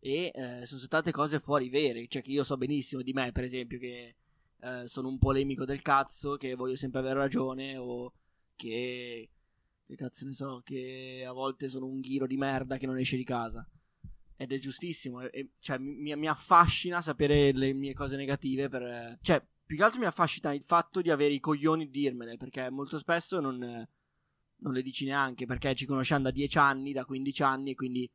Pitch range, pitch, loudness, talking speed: 130-145 Hz, 135 Hz, -31 LUFS, 200 wpm